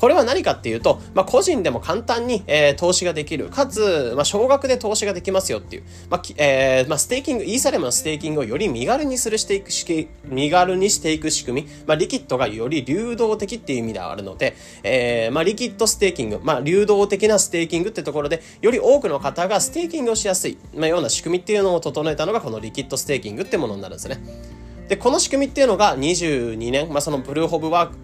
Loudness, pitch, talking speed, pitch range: -20 LUFS, 175 Hz, 495 characters per minute, 145-225 Hz